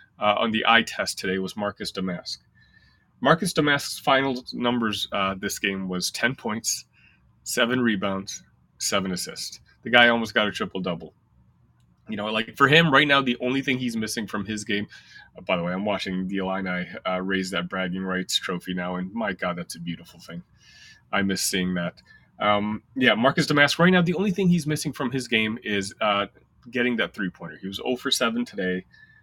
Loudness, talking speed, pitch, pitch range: -24 LUFS, 195 wpm, 105 Hz, 95-125 Hz